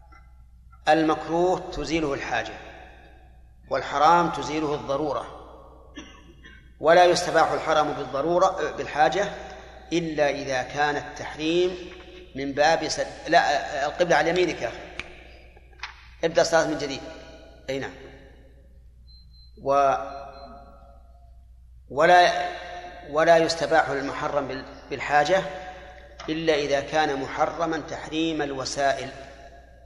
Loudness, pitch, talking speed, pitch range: -24 LUFS, 145 Hz, 80 wpm, 115-165 Hz